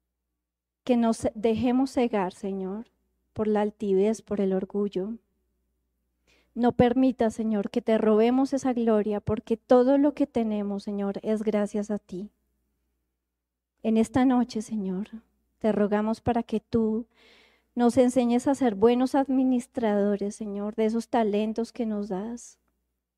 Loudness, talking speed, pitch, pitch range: -26 LUFS, 130 wpm, 220 Hz, 200-235 Hz